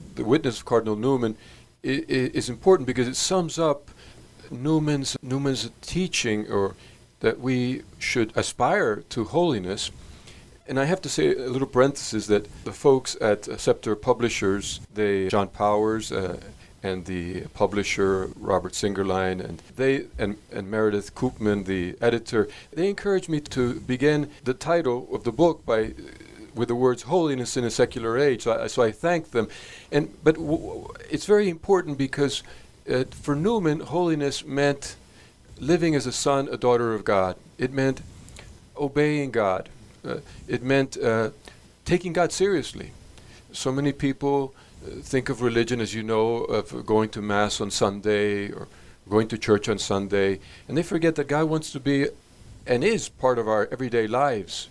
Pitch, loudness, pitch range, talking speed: 125 Hz, -25 LUFS, 105-145 Hz, 160 wpm